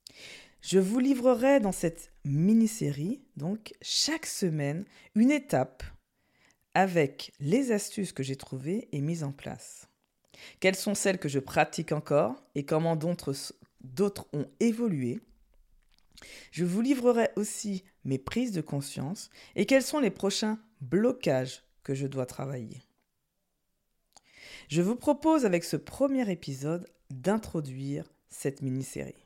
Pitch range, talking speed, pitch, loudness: 140-215 Hz, 125 wpm, 175 Hz, -30 LUFS